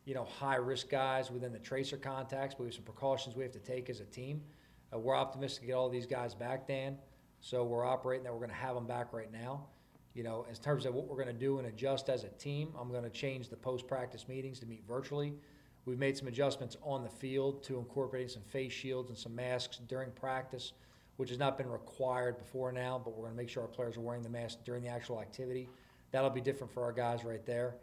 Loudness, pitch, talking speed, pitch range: -40 LUFS, 130 Hz, 250 wpm, 120-135 Hz